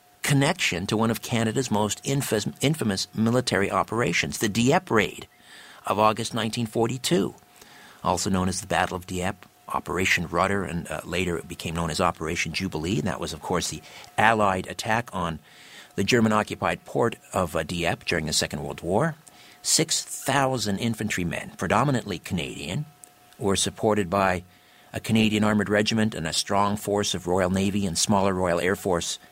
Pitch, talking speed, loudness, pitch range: 100 Hz, 160 wpm, -25 LUFS, 90-115 Hz